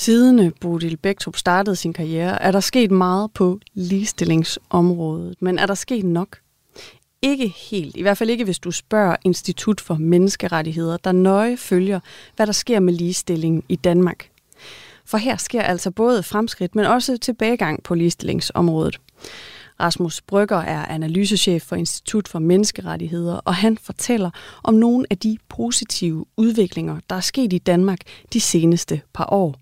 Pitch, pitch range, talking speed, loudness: 185 Hz, 170-215 Hz, 155 wpm, -19 LUFS